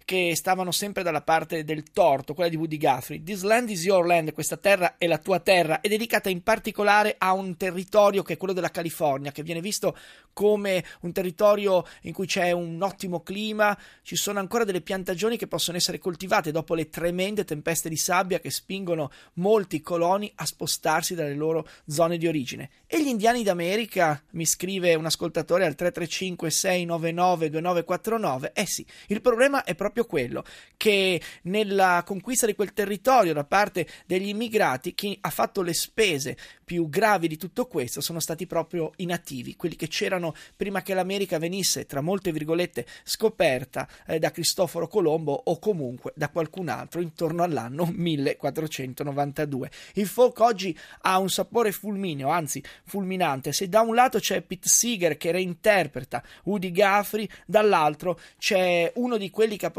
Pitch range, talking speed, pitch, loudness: 165-200 Hz, 165 wpm, 180 Hz, -25 LUFS